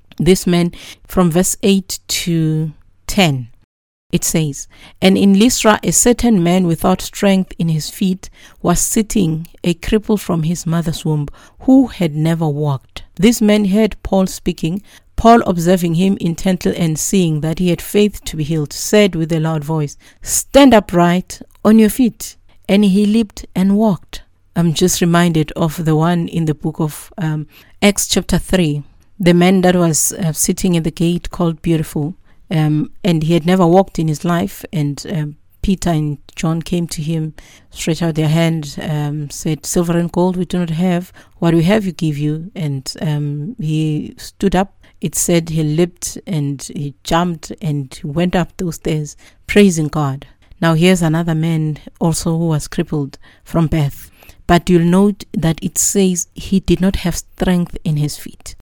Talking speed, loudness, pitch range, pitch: 175 wpm, -15 LUFS, 155-185 Hz, 170 Hz